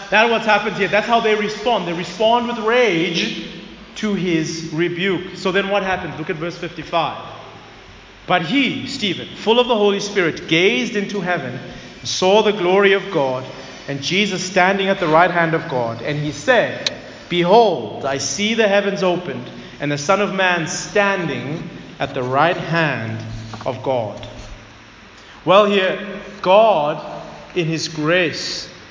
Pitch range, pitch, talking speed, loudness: 150-205 Hz, 180 Hz, 160 wpm, -18 LUFS